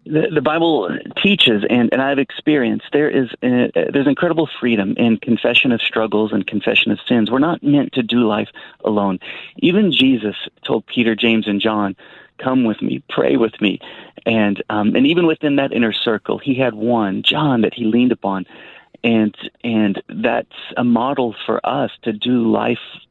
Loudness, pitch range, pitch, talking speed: -17 LUFS, 110-140 Hz, 120 Hz, 175 wpm